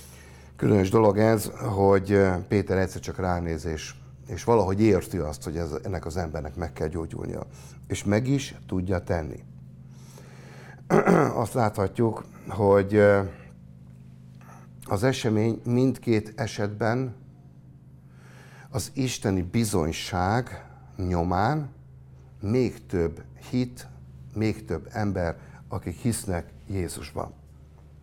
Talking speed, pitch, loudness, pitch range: 95 wpm, 95 Hz, -26 LUFS, 70-115 Hz